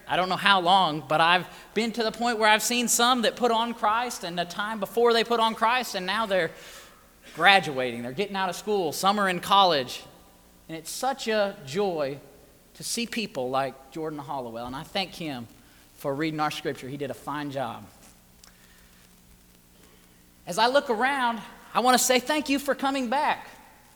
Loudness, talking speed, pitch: -25 LUFS, 195 wpm, 185 Hz